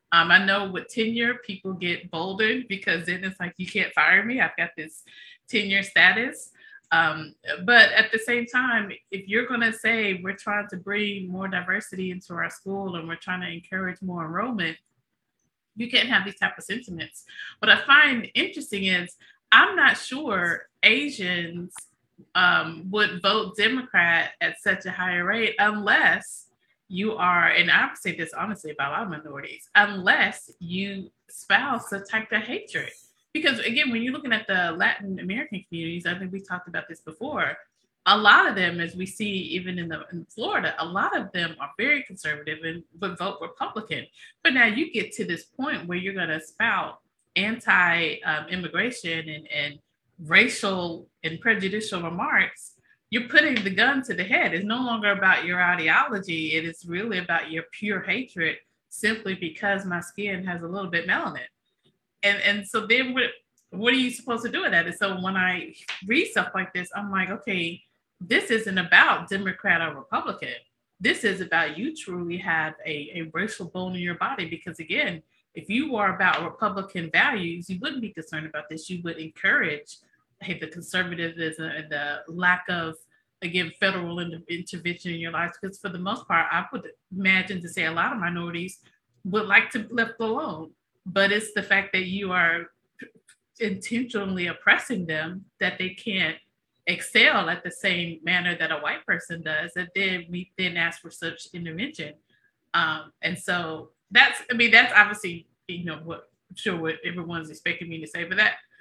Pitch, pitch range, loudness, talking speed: 185 Hz, 170-215 Hz, -23 LUFS, 180 wpm